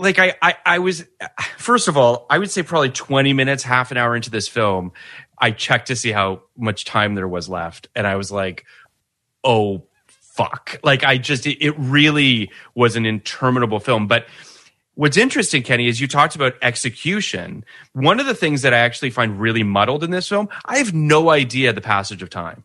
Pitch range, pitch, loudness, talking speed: 110-150 Hz, 130 Hz, -17 LUFS, 200 wpm